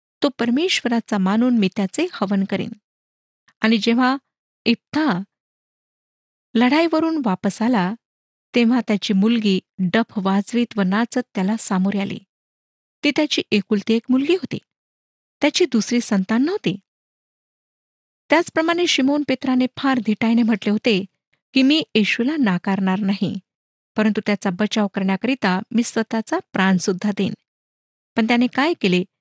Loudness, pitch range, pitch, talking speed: -20 LUFS, 200-255 Hz, 225 Hz, 115 wpm